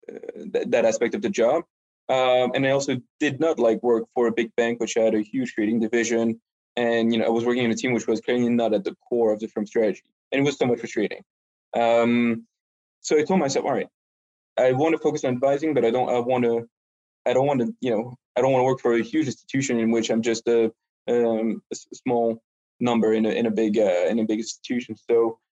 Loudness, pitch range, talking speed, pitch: -23 LUFS, 115-125 Hz, 245 wpm, 115 Hz